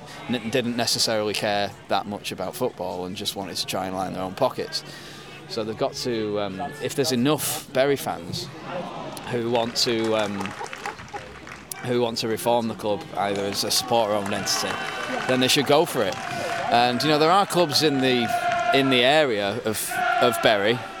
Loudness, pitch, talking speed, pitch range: -23 LUFS, 120 Hz, 185 wpm, 105-135 Hz